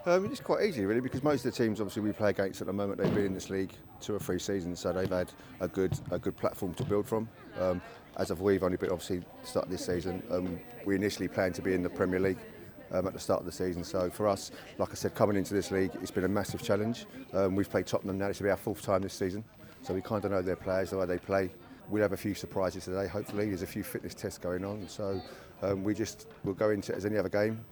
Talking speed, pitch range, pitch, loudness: 275 wpm, 95-105 Hz, 100 Hz, -33 LUFS